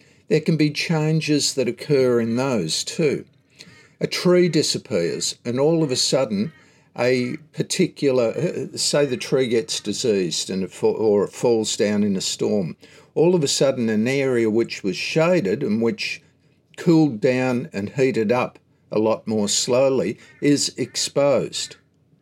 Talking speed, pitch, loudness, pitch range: 145 wpm, 135 Hz, -21 LUFS, 115-155 Hz